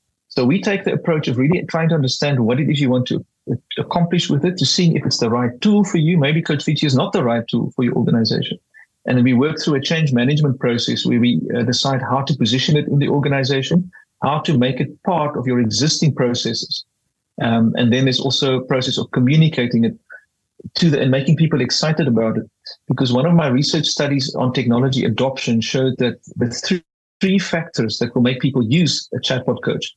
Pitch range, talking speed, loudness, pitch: 125-160 Hz, 215 wpm, -17 LUFS, 135 Hz